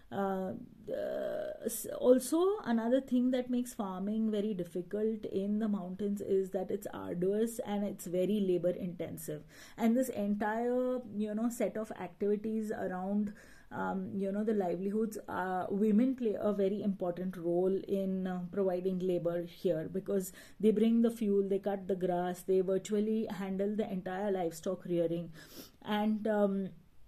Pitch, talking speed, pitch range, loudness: 200 Hz, 145 wpm, 185-220 Hz, -34 LUFS